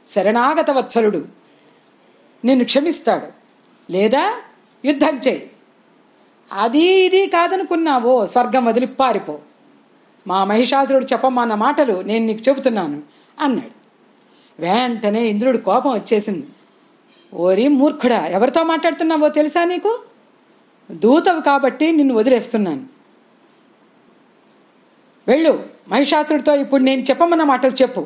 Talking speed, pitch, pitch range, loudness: 90 wpm, 265 Hz, 230-305 Hz, -16 LUFS